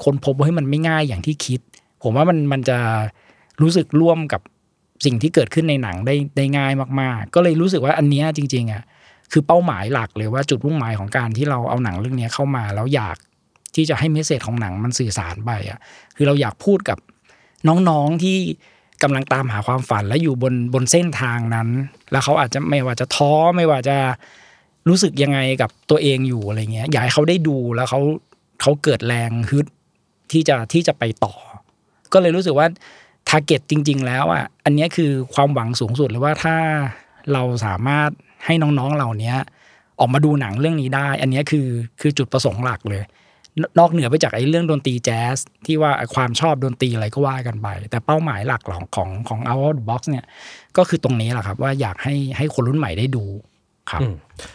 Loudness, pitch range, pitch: -19 LUFS, 120-150 Hz, 135 Hz